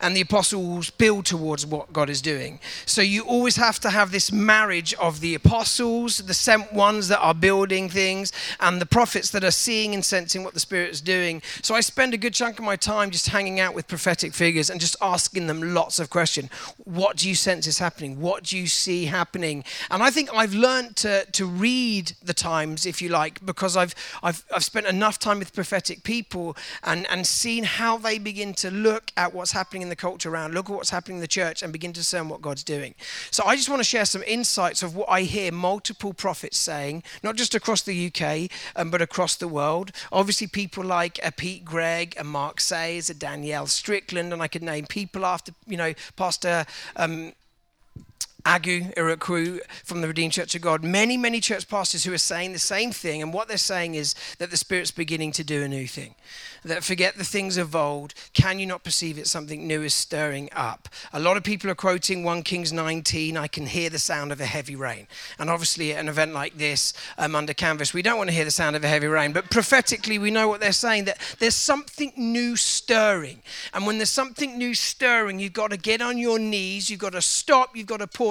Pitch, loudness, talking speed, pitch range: 180 Hz, -23 LUFS, 225 wpm, 165-205 Hz